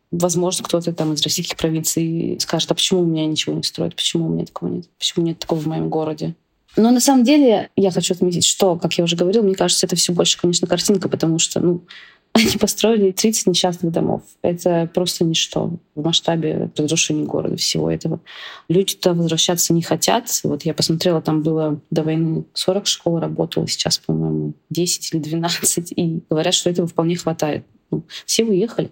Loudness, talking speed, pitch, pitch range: -18 LUFS, 185 wpm, 170 Hz, 160-185 Hz